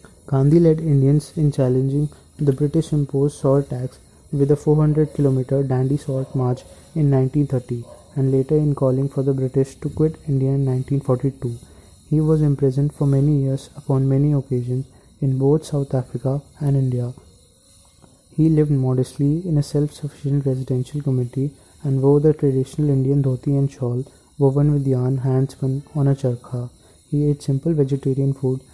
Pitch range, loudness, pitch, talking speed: 130-145 Hz, -20 LUFS, 135 Hz, 150 wpm